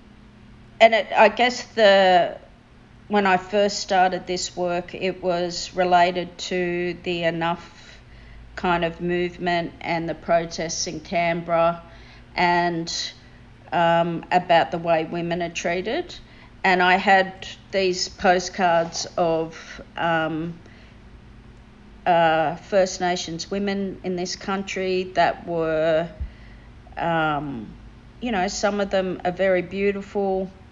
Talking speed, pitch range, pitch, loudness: 115 wpm, 170-190 Hz, 175 Hz, -22 LUFS